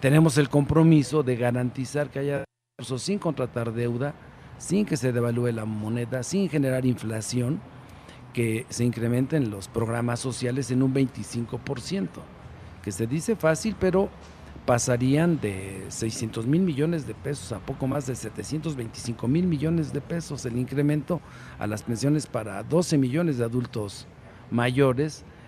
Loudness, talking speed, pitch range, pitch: -26 LUFS, 145 wpm, 120-150 Hz, 130 Hz